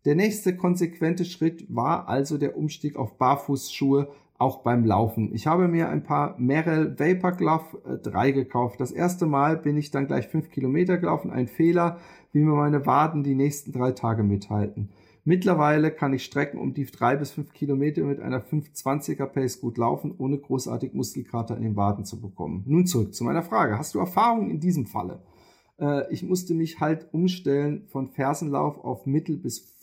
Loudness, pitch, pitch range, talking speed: -25 LUFS, 145 Hz, 130-160 Hz, 185 wpm